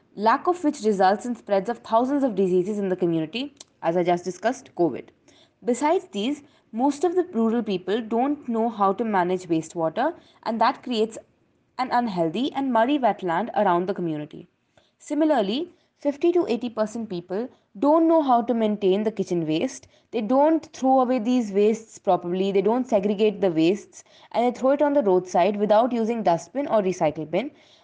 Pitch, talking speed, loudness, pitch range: 225 Hz, 175 wpm, -23 LUFS, 190-265 Hz